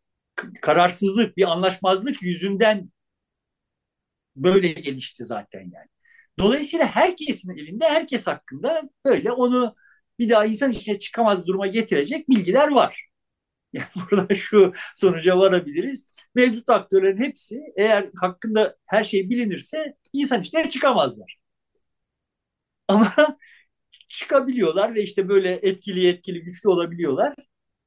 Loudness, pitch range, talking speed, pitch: -21 LUFS, 190-265 Hz, 105 wpm, 215 Hz